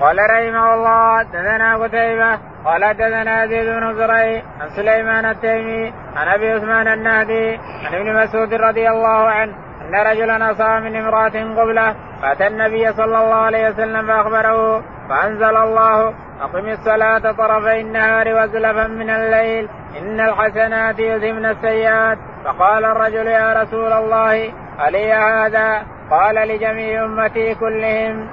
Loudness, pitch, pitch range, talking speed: -15 LUFS, 220 Hz, 220-225 Hz, 125 wpm